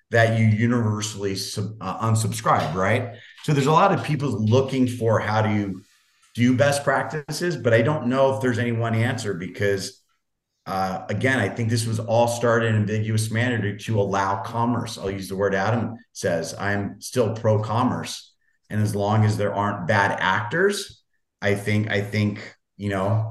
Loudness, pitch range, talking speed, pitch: -23 LUFS, 100-120 Hz, 175 wpm, 110 Hz